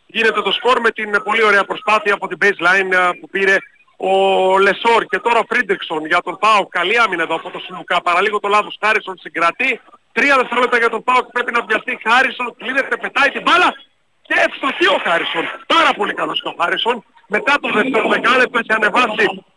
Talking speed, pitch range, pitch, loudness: 190 wpm, 195-245 Hz, 215 Hz, -15 LUFS